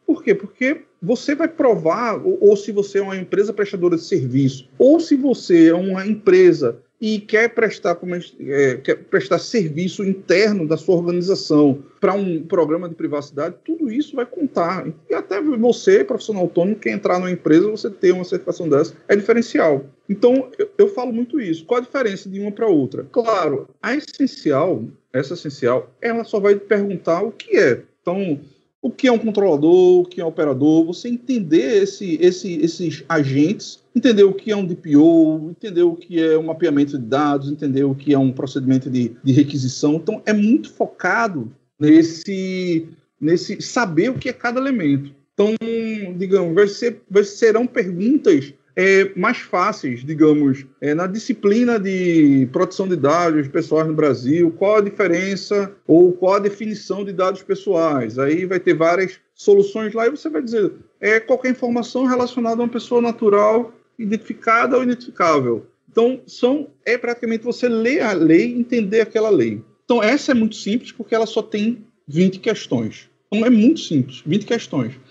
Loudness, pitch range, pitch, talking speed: -18 LUFS, 165-235 Hz, 200 Hz, 175 wpm